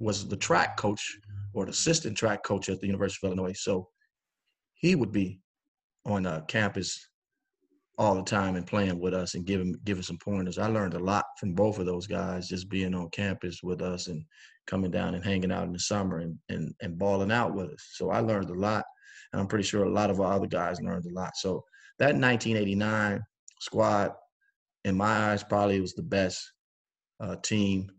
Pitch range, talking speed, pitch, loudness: 90-105 Hz, 205 wpm, 100 Hz, -29 LUFS